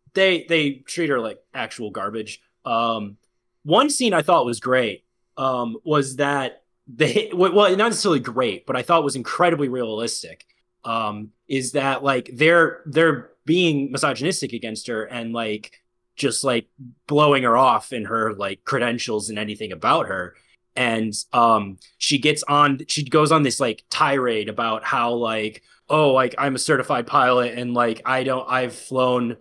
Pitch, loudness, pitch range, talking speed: 130 Hz, -21 LUFS, 115-150 Hz, 165 wpm